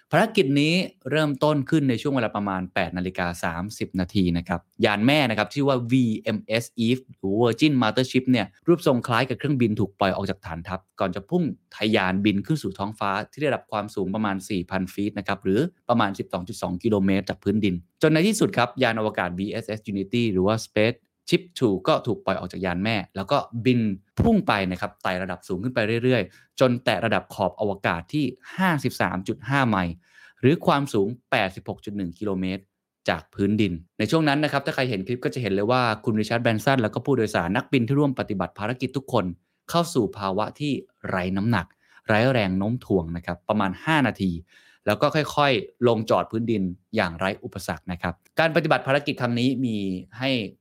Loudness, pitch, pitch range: -24 LUFS, 110 Hz, 95-130 Hz